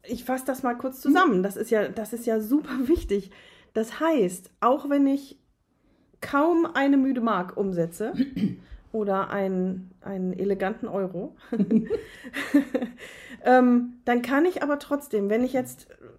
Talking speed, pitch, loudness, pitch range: 135 wpm, 245 Hz, -25 LUFS, 200-275 Hz